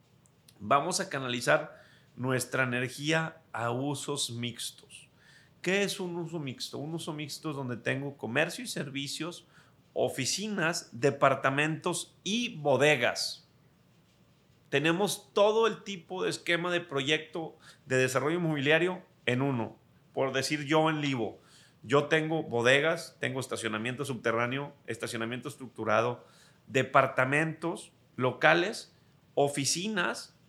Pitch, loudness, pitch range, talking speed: 145 Hz, -30 LUFS, 130-165 Hz, 110 wpm